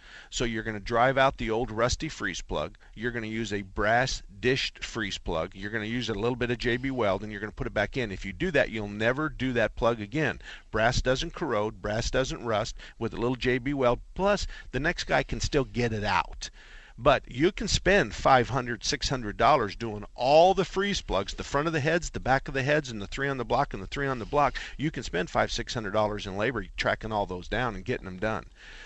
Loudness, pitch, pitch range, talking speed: -28 LUFS, 120 Hz, 105-135 Hz, 250 wpm